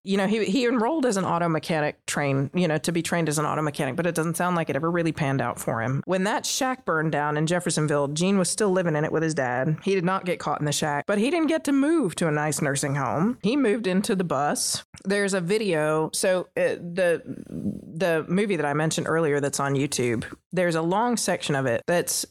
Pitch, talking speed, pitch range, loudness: 170 Hz, 250 wpm, 150-195 Hz, -24 LUFS